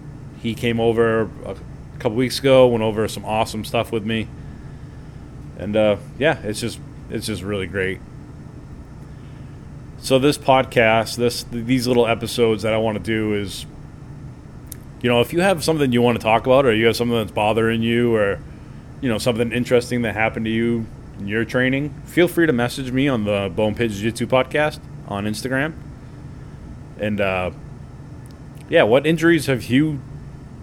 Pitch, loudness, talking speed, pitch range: 120 Hz, -19 LUFS, 170 wpm, 110-135 Hz